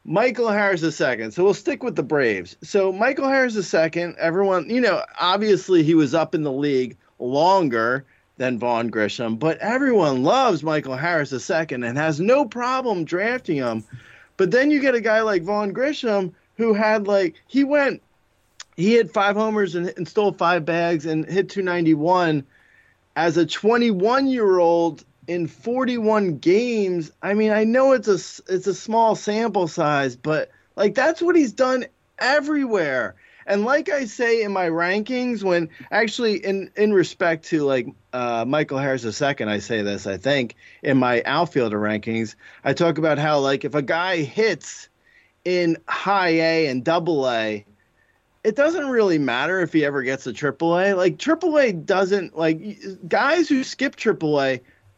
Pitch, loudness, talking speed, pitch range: 180 Hz, -21 LUFS, 165 wpm, 150-220 Hz